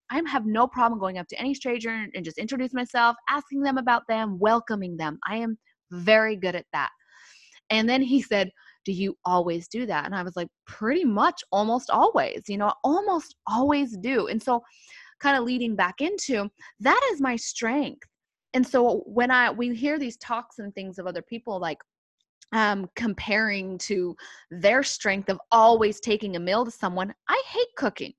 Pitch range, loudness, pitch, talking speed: 195-260 Hz, -25 LUFS, 230 Hz, 185 wpm